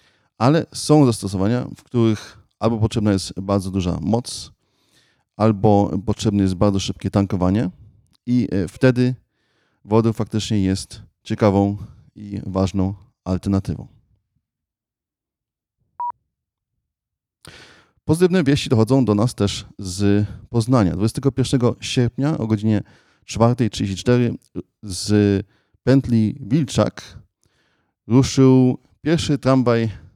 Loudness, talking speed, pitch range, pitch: -19 LUFS, 90 wpm, 100-125 Hz, 110 Hz